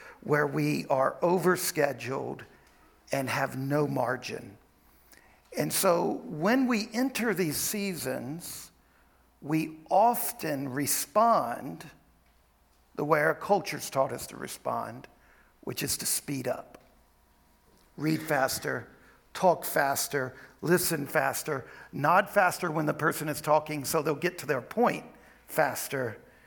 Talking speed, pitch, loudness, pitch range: 115 wpm, 150 Hz, -29 LUFS, 135-175 Hz